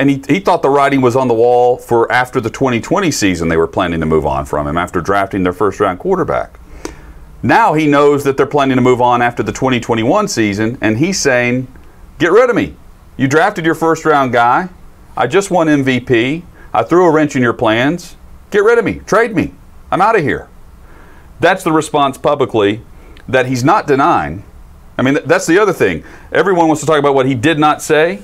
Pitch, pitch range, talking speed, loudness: 130 Hz, 115-155 Hz, 215 wpm, -13 LUFS